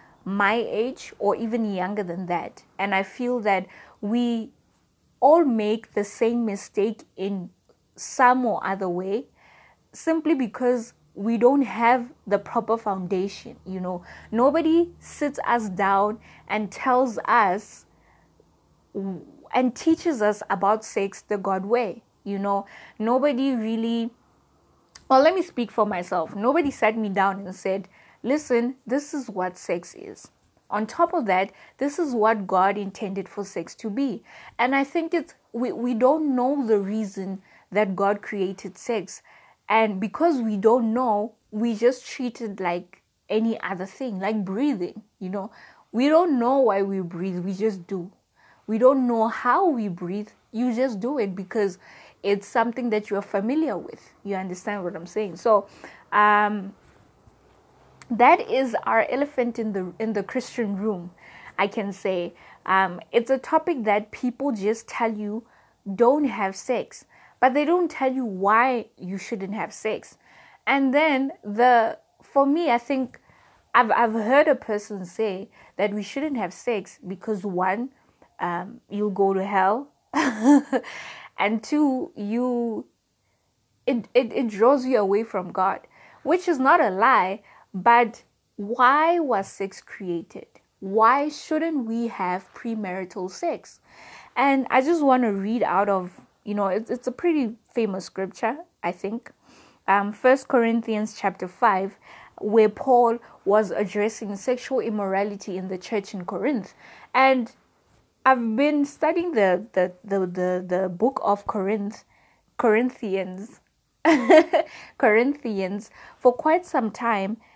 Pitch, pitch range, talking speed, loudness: 220 Hz, 195-255 Hz, 145 wpm, -24 LUFS